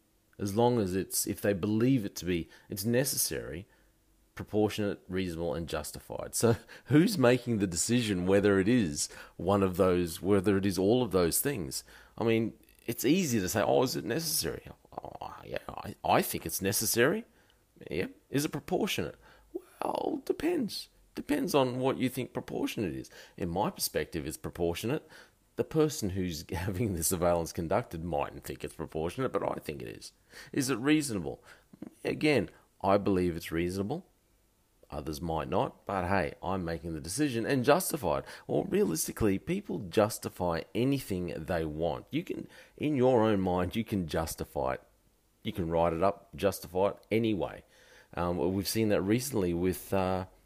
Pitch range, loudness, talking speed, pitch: 90-120 Hz, -31 LUFS, 165 wpm, 100 Hz